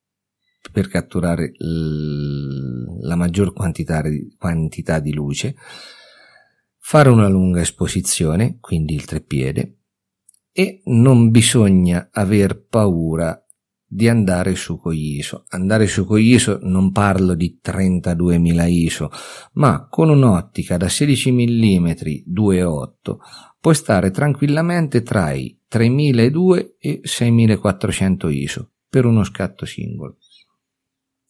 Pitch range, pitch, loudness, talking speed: 85-115 Hz, 95 Hz, -17 LUFS, 100 wpm